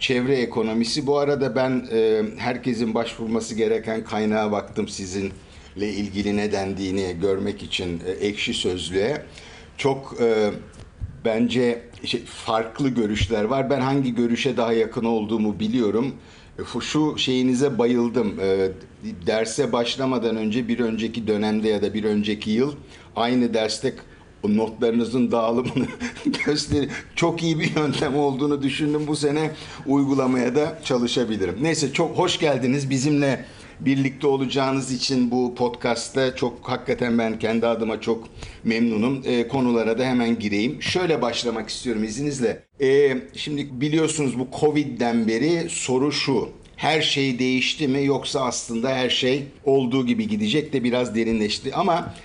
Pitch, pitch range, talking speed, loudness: 125 Hz, 110-140 Hz, 125 wpm, -23 LUFS